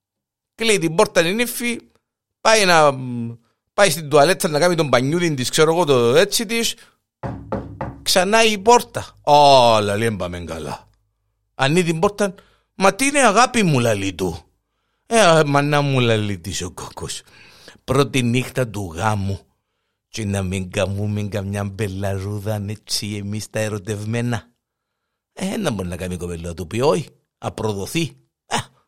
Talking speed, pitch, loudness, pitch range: 140 wpm, 115 Hz, -18 LUFS, 105-165 Hz